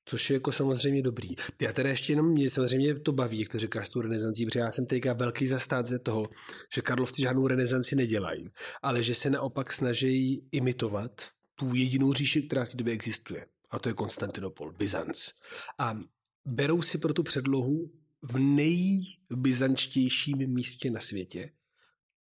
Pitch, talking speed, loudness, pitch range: 130 Hz, 165 wpm, -29 LUFS, 120-140 Hz